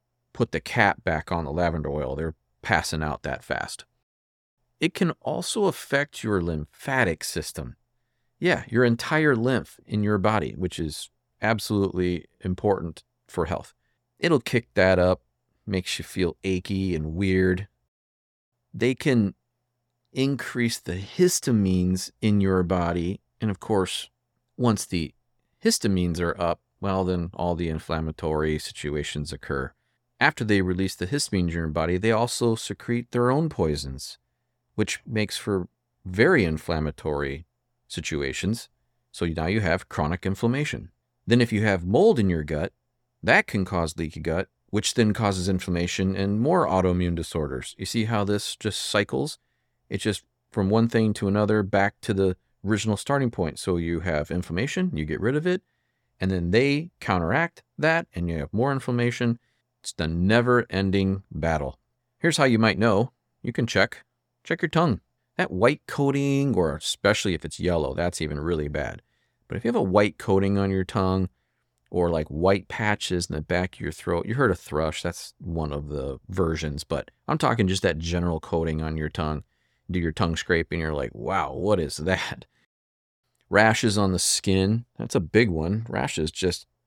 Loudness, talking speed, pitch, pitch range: -25 LUFS, 165 wpm, 95 Hz, 80-115 Hz